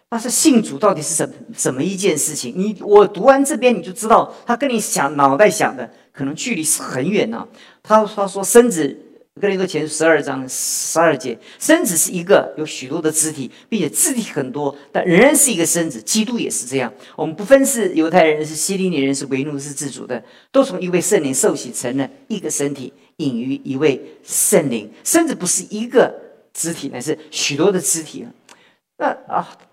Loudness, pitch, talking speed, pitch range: -17 LUFS, 180 Hz, 295 characters per minute, 150-230 Hz